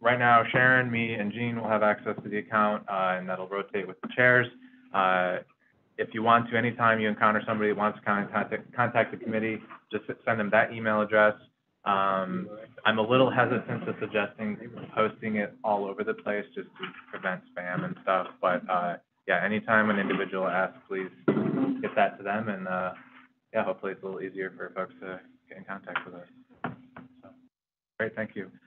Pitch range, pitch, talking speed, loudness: 100-120 Hz, 110 Hz, 195 wpm, -27 LUFS